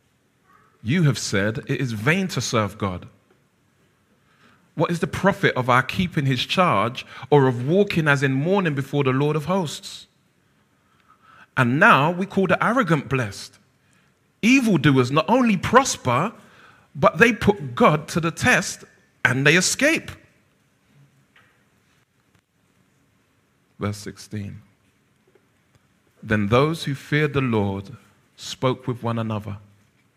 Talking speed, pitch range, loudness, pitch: 125 wpm, 115-170 Hz, -20 LUFS, 135 Hz